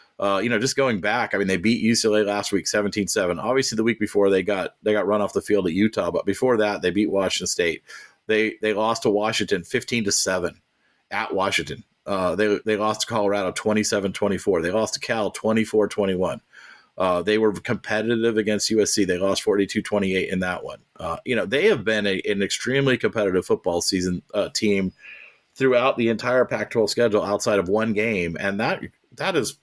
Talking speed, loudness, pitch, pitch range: 190 wpm, -22 LUFS, 105 Hz, 100-110 Hz